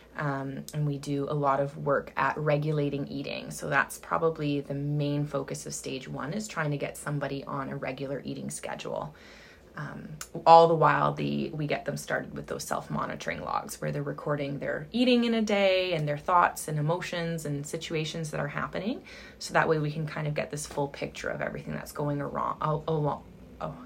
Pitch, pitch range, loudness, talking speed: 150 Hz, 140-160 Hz, -29 LUFS, 205 wpm